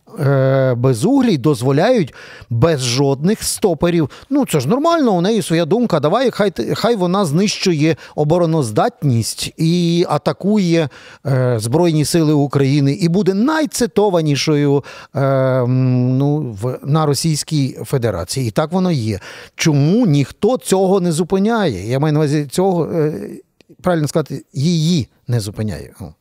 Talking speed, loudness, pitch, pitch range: 125 wpm, -16 LUFS, 155 Hz, 135-180 Hz